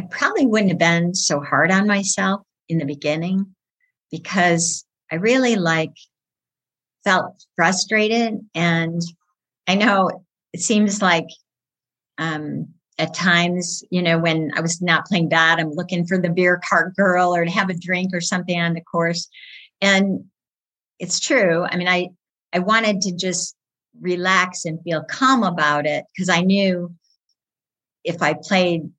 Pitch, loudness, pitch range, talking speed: 180 Hz, -19 LUFS, 165-190 Hz, 155 wpm